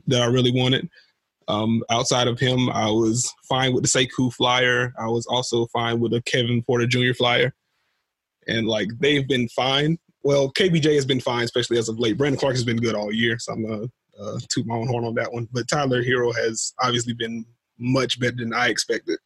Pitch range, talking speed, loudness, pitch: 115-130 Hz, 215 wpm, -22 LUFS, 125 Hz